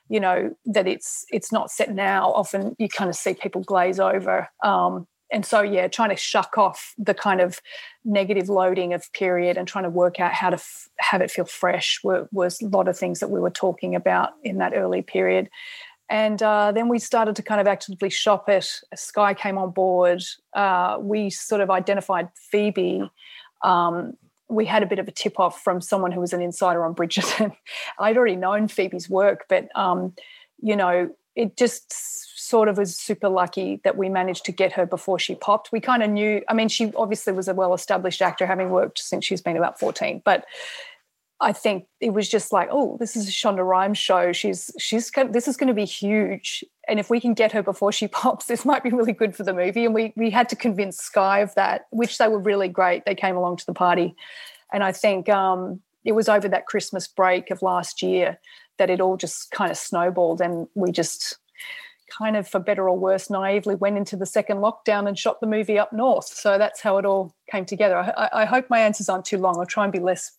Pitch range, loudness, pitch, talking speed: 185-220 Hz, -22 LUFS, 200 Hz, 220 wpm